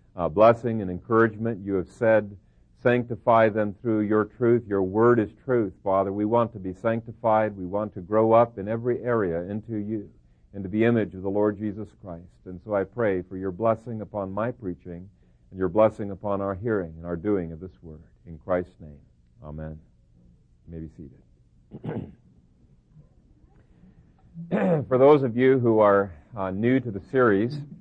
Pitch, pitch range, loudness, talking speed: 105 Hz, 90-115 Hz, -24 LUFS, 175 wpm